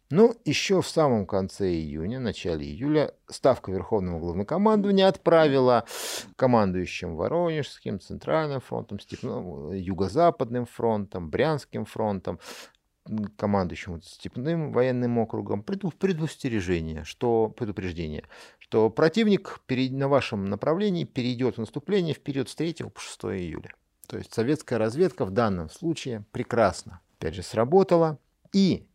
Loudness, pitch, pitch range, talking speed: -26 LUFS, 125 Hz, 100-155 Hz, 110 wpm